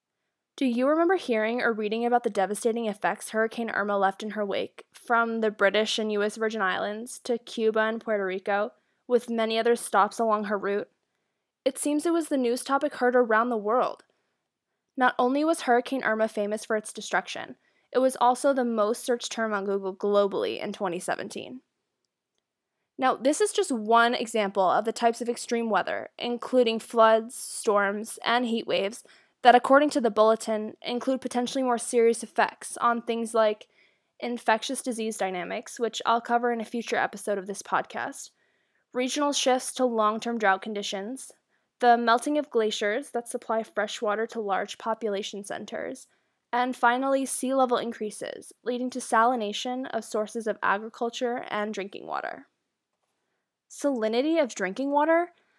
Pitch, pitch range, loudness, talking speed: 230 Hz, 215-250 Hz, -26 LUFS, 160 wpm